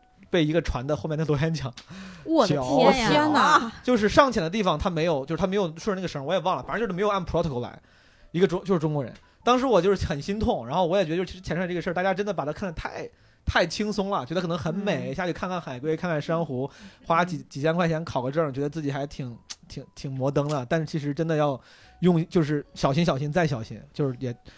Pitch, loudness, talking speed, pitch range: 170 Hz, -25 LUFS, 375 characters per minute, 150-190 Hz